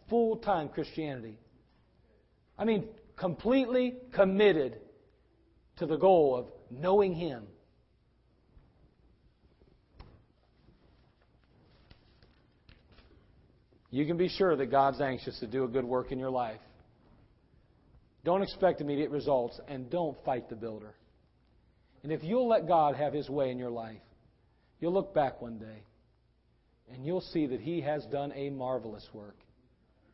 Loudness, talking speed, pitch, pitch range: -31 LUFS, 125 wpm, 140 Hz, 120-175 Hz